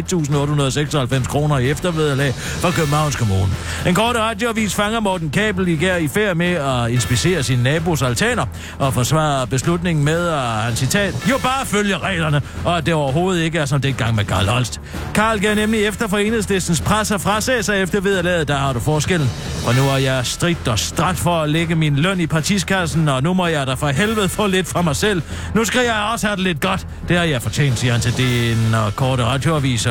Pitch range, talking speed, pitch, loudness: 130-190 Hz, 215 wpm, 160 Hz, -18 LUFS